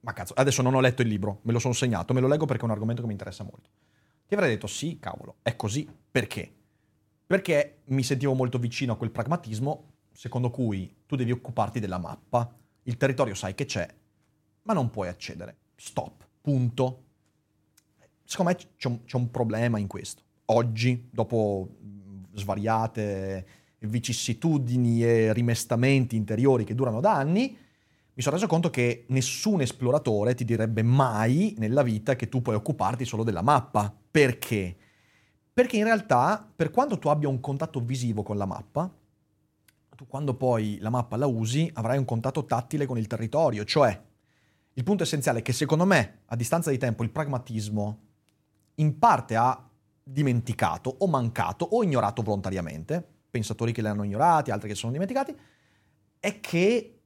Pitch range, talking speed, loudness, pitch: 110-140 Hz, 165 wpm, -27 LUFS, 120 Hz